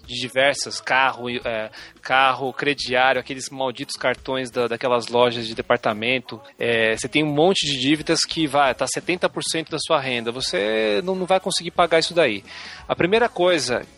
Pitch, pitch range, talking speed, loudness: 135 Hz, 125-160 Hz, 165 wpm, -21 LUFS